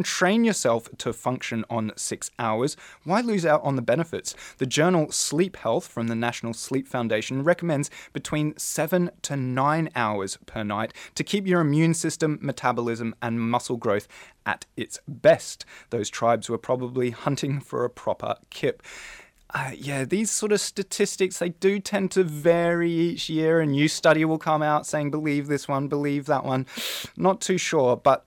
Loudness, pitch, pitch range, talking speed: -25 LUFS, 150 Hz, 125-170 Hz, 170 wpm